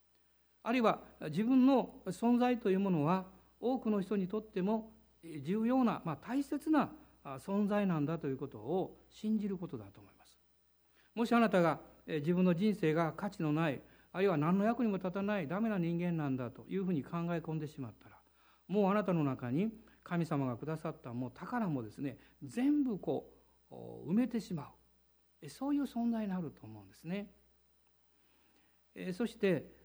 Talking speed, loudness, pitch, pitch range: 320 characters per minute, -35 LUFS, 180 Hz, 140-215 Hz